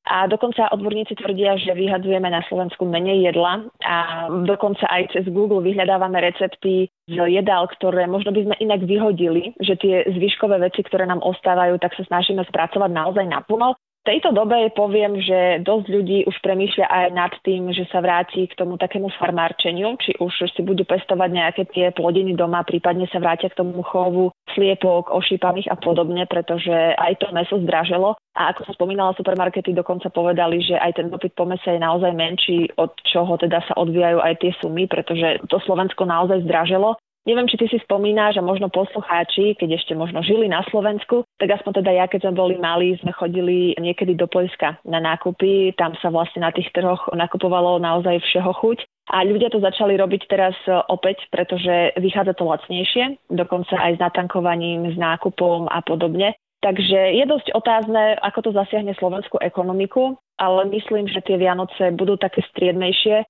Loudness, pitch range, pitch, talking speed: -19 LUFS, 175-200 Hz, 185 Hz, 175 wpm